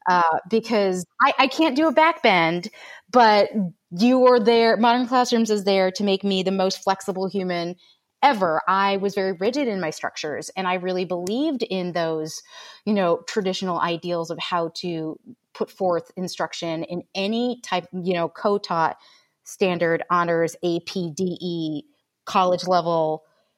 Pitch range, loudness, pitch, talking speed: 175-220 Hz, -22 LUFS, 190 Hz, 150 wpm